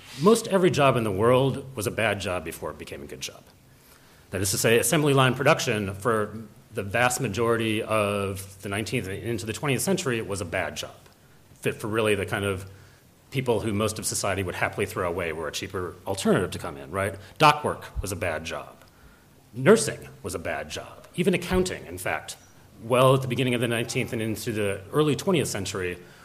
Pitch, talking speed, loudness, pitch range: 115 Hz, 210 wpm, -25 LUFS, 100-130 Hz